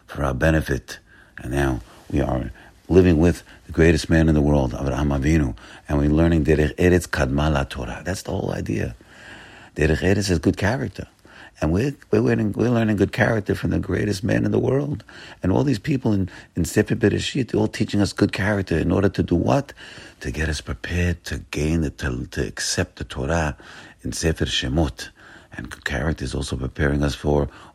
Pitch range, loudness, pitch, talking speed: 75-100 Hz, -22 LUFS, 85 Hz, 195 wpm